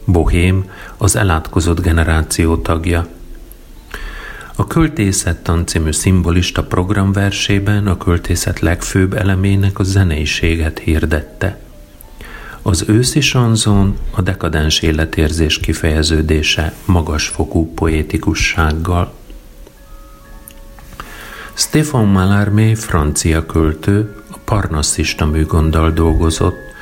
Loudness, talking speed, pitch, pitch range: -14 LUFS, 75 wpm, 85 Hz, 80-100 Hz